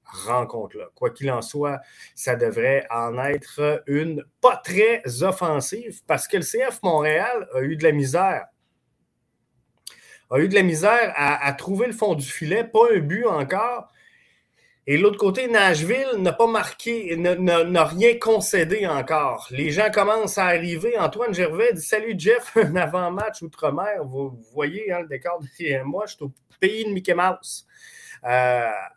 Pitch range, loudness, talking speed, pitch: 145-220 Hz, -22 LUFS, 165 wpm, 180 Hz